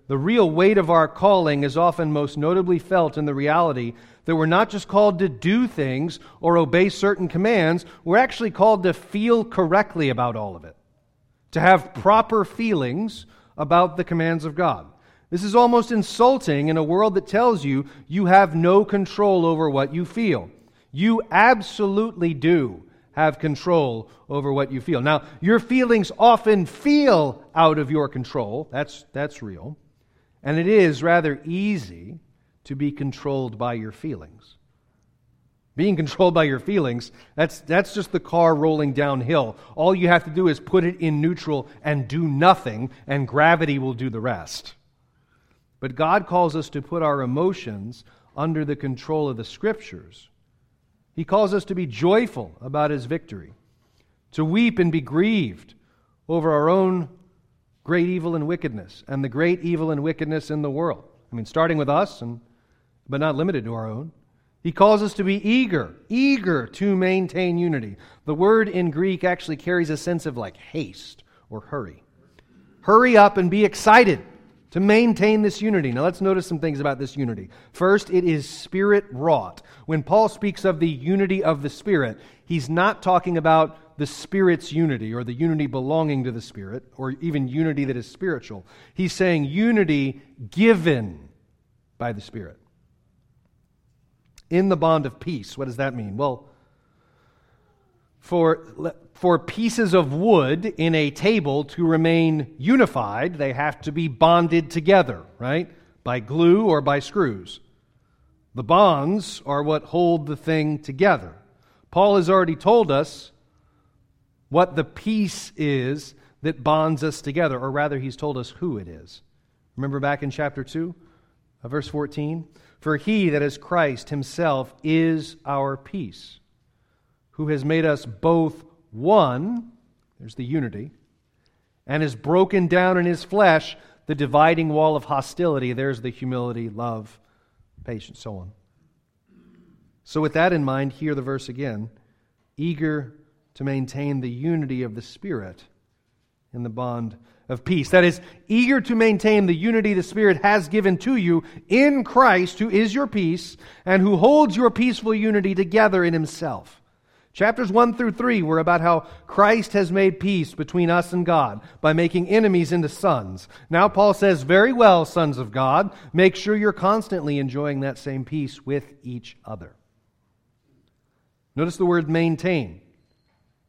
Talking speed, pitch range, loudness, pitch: 160 wpm, 135-185 Hz, -21 LUFS, 160 Hz